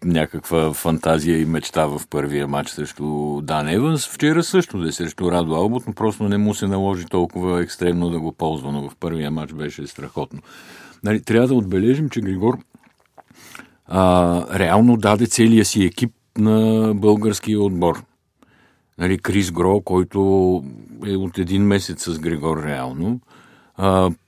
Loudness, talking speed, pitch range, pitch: -19 LUFS, 150 wpm, 80-105 Hz, 90 Hz